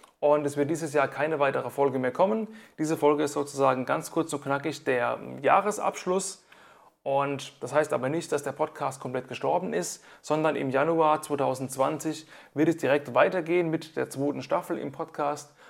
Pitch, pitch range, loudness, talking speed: 150 Hz, 140-160 Hz, -27 LUFS, 170 wpm